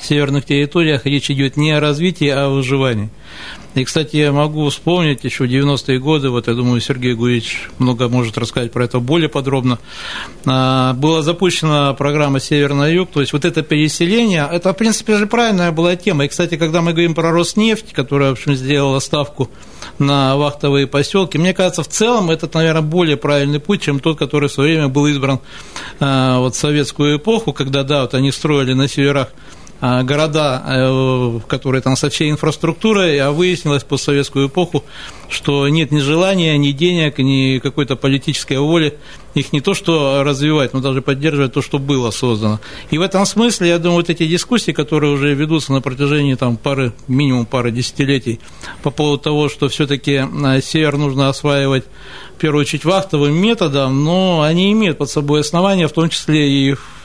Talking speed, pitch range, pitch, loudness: 175 wpm, 135-160 Hz, 145 Hz, -15 LUFS